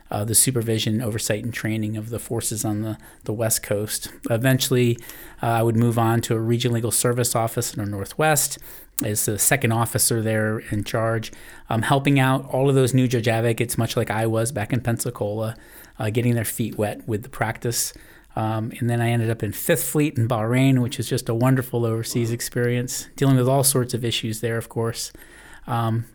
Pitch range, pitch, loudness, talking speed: 110-125 Hz, 115 Hz, -22 LUFS, 200 wpm